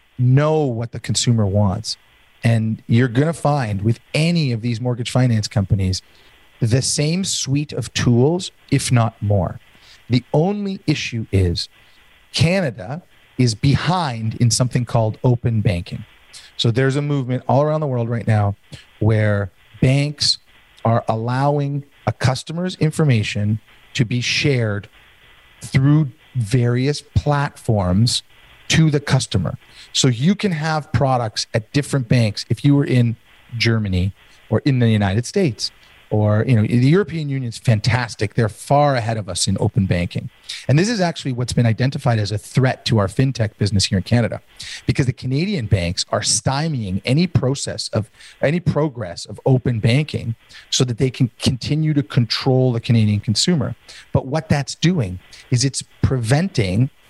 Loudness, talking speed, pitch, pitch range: -19 LUFS, 150 wpm, 125 Hz, 110-145 Hz